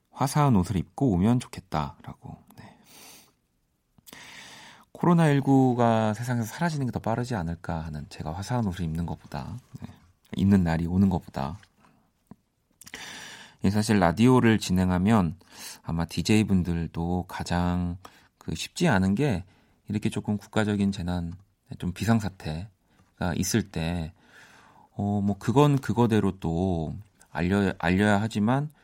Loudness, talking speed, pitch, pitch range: -26 LUFS, 255 characters per minute, 100 Hz, 85-115 Hz